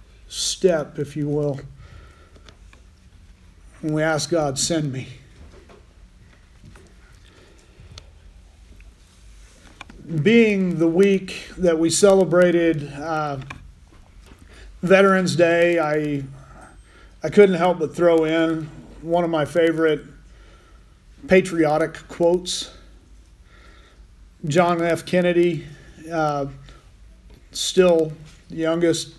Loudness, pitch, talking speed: -20 LUFS, 150 Hz, 80 wpm